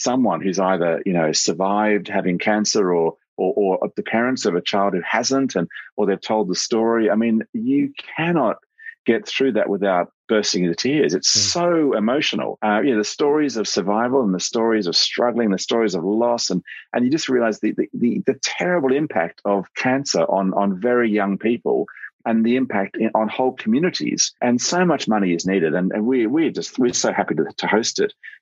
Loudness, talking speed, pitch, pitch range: -20 LUFS, 215 wpm, 110 Hz, 100-130 Hz